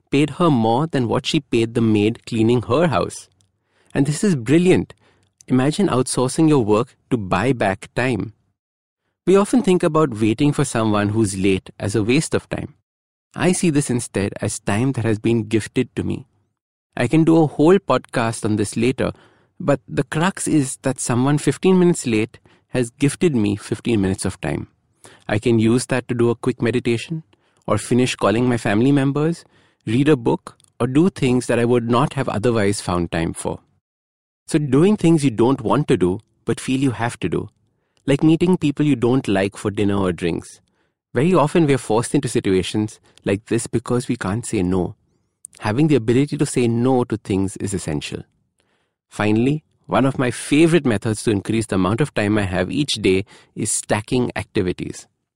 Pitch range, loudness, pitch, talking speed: 105-145 Hz, -19 LUFS, 120 Hz, 185 wpm